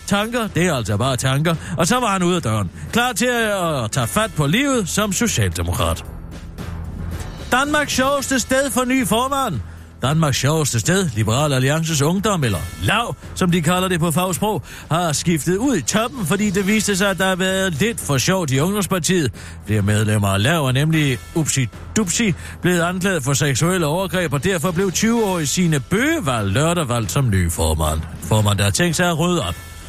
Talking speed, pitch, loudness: 190 wpm, 165 Hz, -18 LUFS